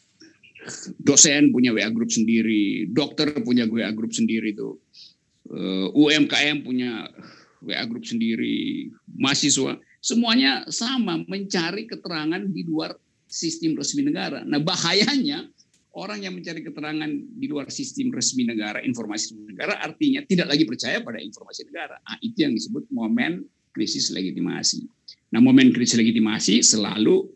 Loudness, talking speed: -22 LUFS, 130 wpm